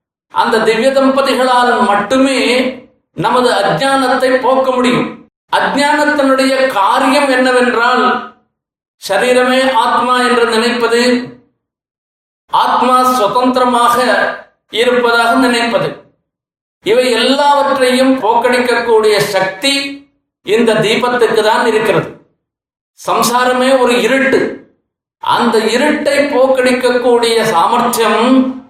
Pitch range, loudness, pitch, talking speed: 235-265 Hz, -11 LUFS, 250 Hz, 70 wpm